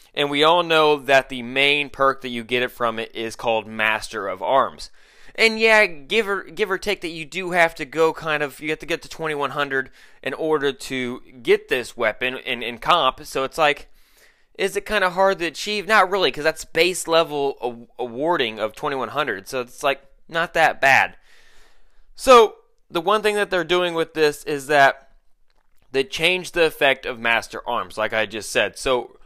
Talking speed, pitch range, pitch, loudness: 205 wpm, 135-185 Hz, 155 Hz, -20 LUFS